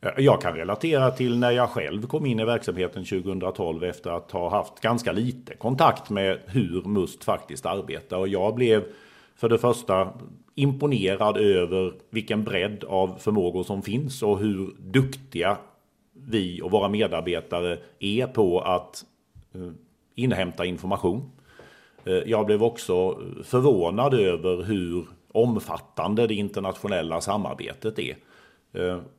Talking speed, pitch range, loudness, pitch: 125 wpm, 90-120 Hz, -25 LUFS, 105 Hz